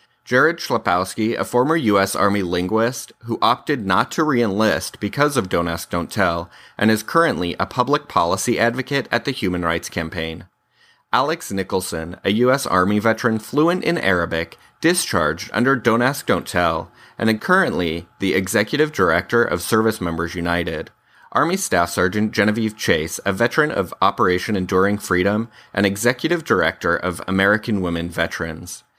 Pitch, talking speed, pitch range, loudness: 100 Hz, 155 wpm, 85-120 Hz, -19 LUFS